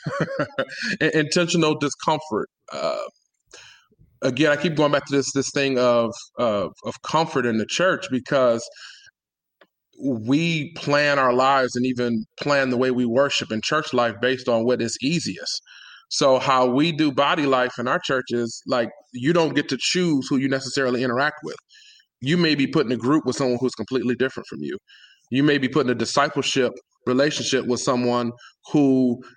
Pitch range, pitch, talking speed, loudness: 125-150 Hz, 135 Hz, 170 wpm, -22 LUFS